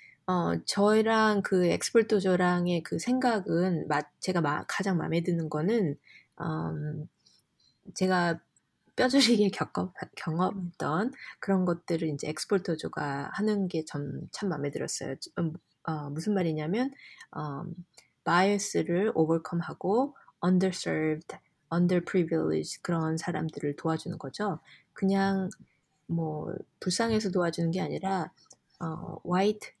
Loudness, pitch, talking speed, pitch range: -29 LUFS, 175 Hz, 255 characters per minute, 160-195 Hz